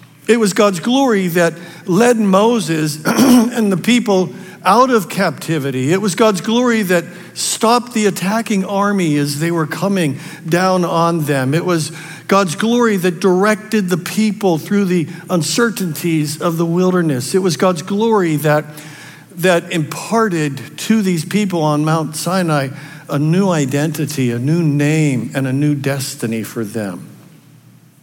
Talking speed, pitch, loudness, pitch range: 145 wpm, 175 Hz, -15 LUFS, 155-200 Hz